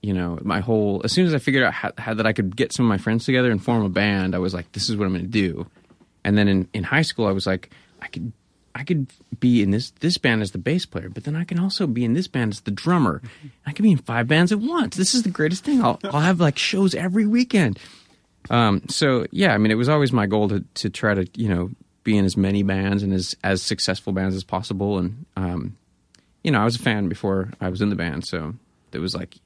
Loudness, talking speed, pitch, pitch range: -21 LUFS, 275 wpm, 110 Hz, 95-145 Hz